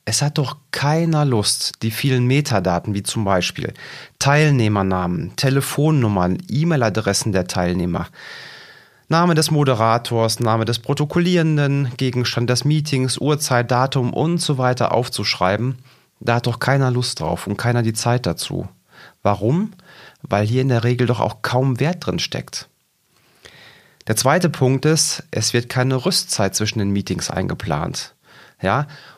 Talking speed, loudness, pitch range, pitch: 140 wpm, -19 LUFS, 110-145 Hz, 125 Hz